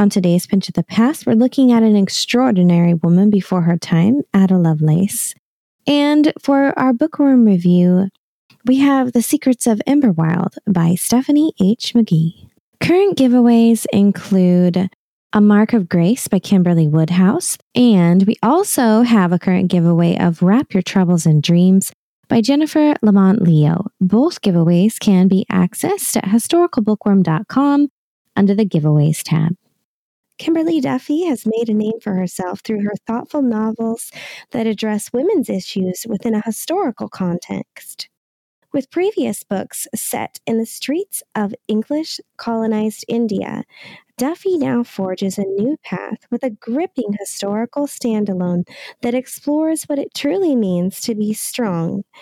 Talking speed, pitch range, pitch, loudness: 140 wpm, 185-260 Hz, 220 Hz, -16 LUFS